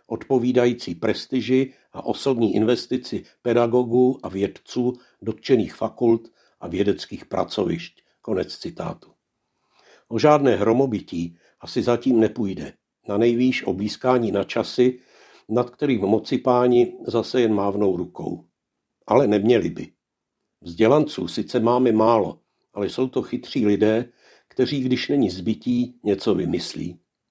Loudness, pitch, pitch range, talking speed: -22 LUFS, 120 Hz, 105-125 Hz, 115 wpm